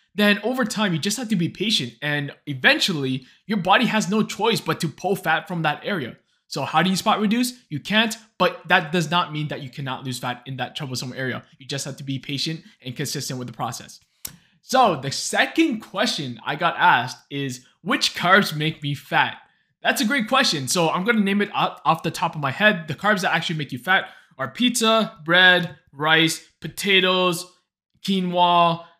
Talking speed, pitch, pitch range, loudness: 200 wpm, 170 Hz, 145-205 Hz, -21 LUFS